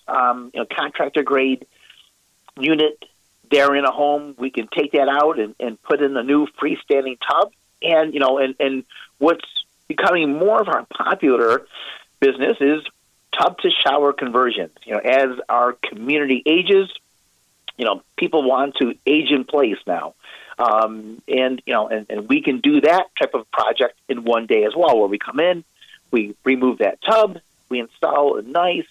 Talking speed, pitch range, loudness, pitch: 175 wpm, 130-160 Hz, -19 LUFS, 140 Hz